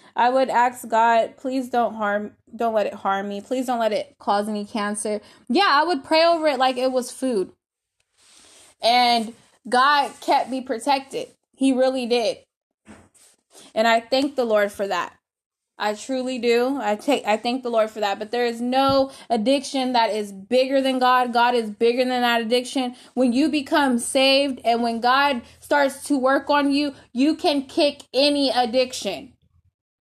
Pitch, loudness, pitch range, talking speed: 255 Hz, -21 LUFS, 230-275 Hz, 175 wpm